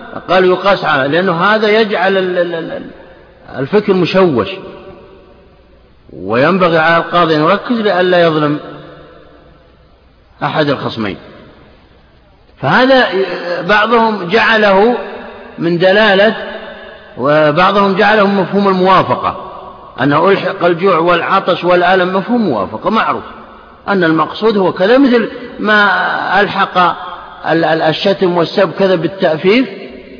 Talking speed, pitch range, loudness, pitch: 90 wpm, 170-205 Hz, -11 LUFS, 190 Hz